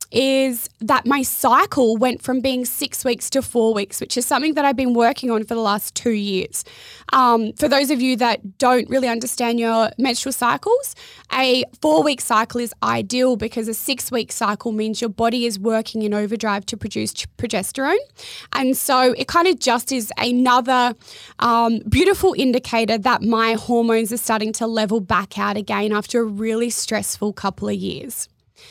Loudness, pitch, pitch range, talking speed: -19 LUFS, 235 Hz, 220-255 Hz, 180 wpm